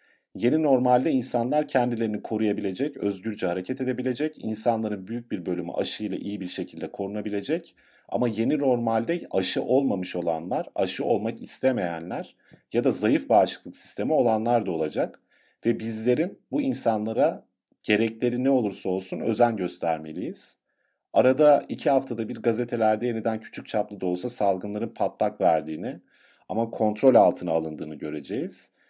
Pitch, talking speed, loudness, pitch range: 115 Hz, 130 wpm, -26 LUFS, 105-125 Hz